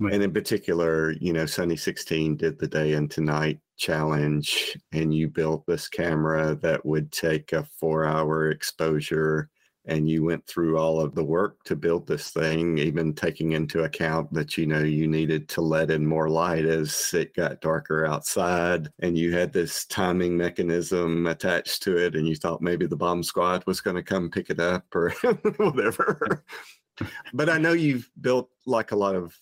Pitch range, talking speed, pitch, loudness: 80-90 Hz, 185 wpm, 80 Hz, -25 LUFS